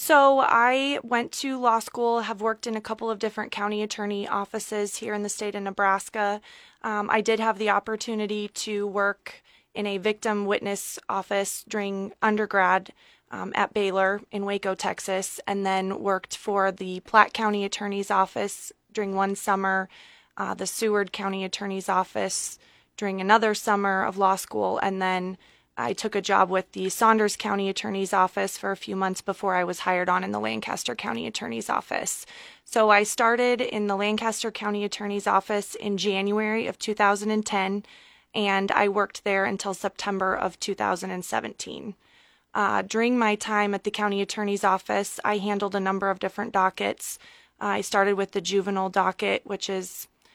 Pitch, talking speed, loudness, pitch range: 205 Hz, 165 wpm, -26 LUFS, 195-215 Hz